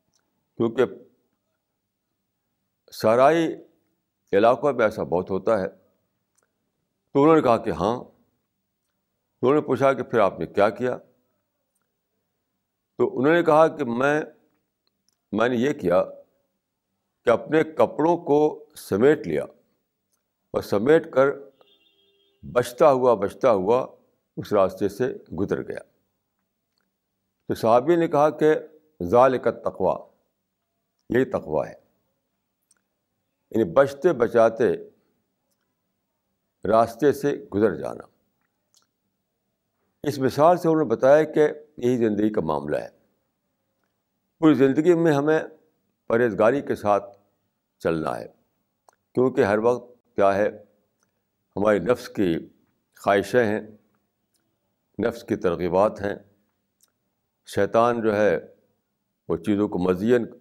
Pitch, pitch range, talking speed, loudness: 125 Hz, 105-150 Hz, 110 wpm, -22 LUFS